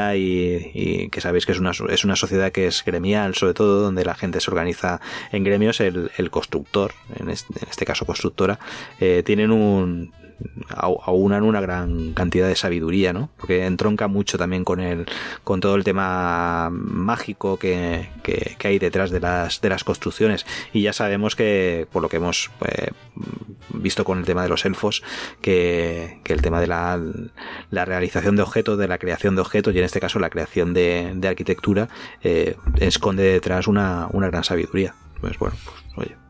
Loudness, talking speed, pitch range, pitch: -21 LUFS, 185 wpm, 90-100 Hz, 90 Hz